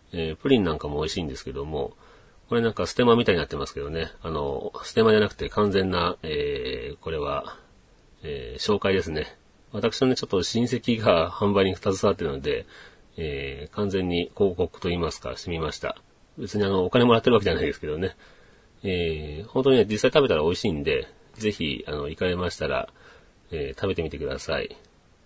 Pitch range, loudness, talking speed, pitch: 90-120 Hz, -25 LUFS, 390 characters per minute, 105 Hz